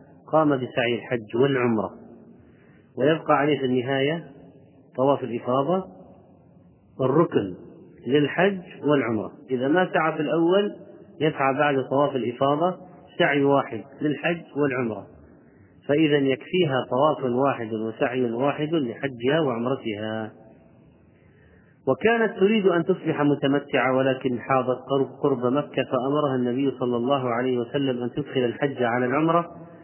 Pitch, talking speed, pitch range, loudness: 140 Hz, 110 wpm, 125-150 Hz, -24 LUFS